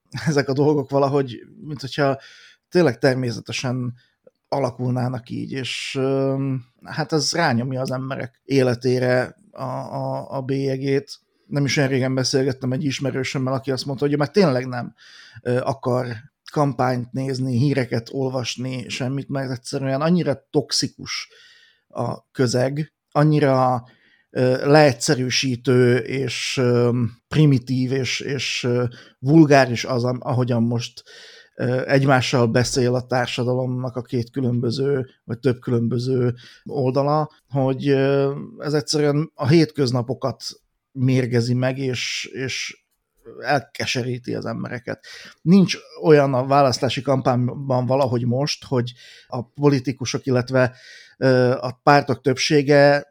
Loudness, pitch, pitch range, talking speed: -21 LUFS, 130 Hz, 125-140 Hz, 105 wpm